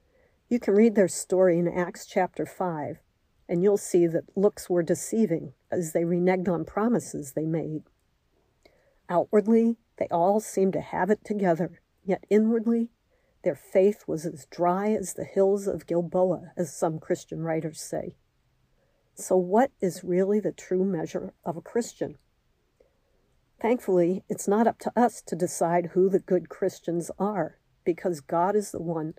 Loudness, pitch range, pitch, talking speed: -26 LUFS, 170-210 Hz, 185 Hz, 155 wpm